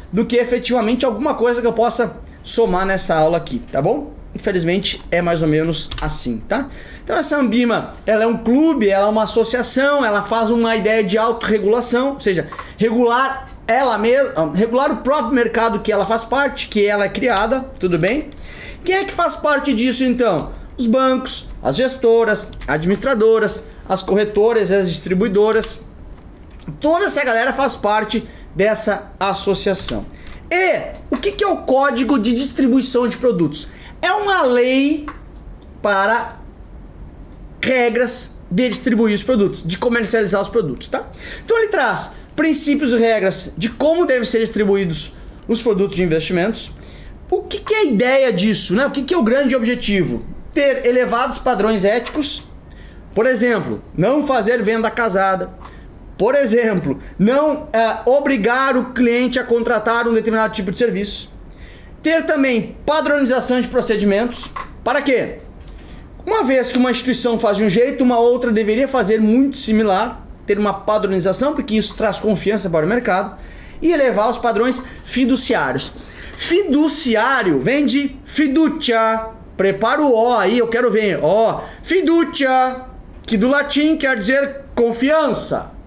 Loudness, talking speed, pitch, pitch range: -17 LUFS, 150 wpm, 235 Hz, 210-265 Hz